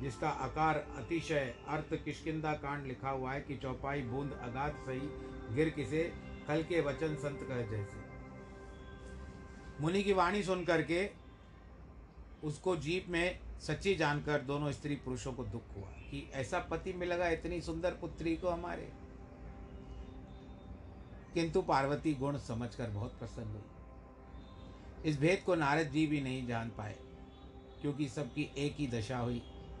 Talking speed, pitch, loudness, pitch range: 140 wpm, 140 Hz, -37 LUFS, 100-155 Hz